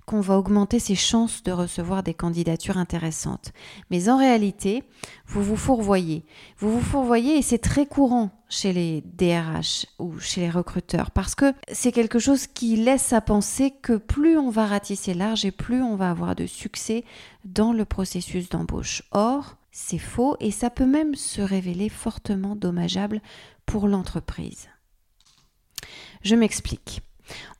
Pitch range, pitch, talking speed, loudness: 180-235 Hz, 205 Hz, 155 wpm, -24 LUFS